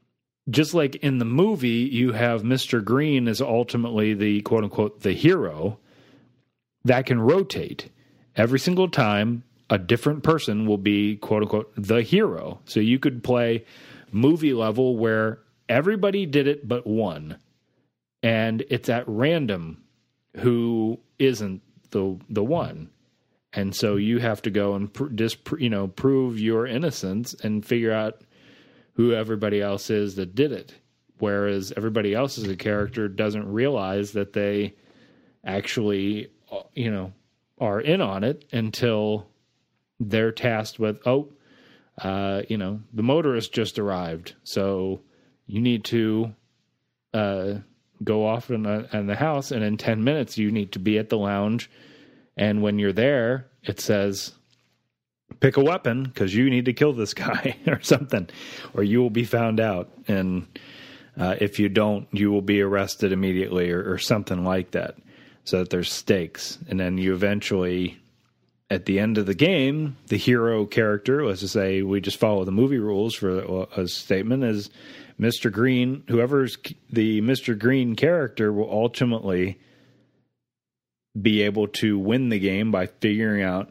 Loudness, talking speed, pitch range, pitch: -24 LUFS, 155 wpm, 100-120 Hz, 110 Hz